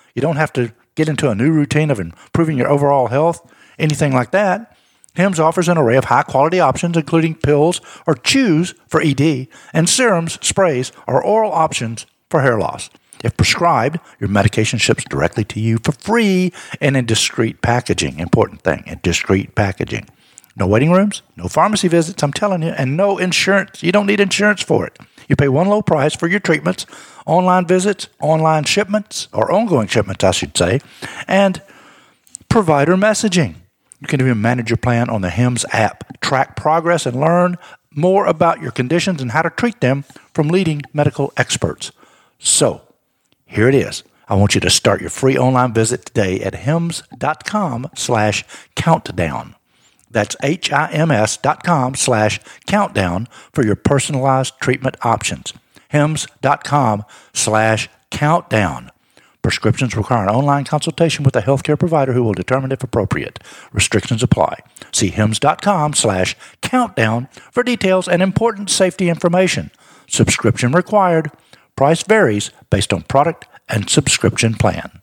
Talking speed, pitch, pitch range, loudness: 150 wpm, 145 Hz, 115-175 Hz, -16 LUFS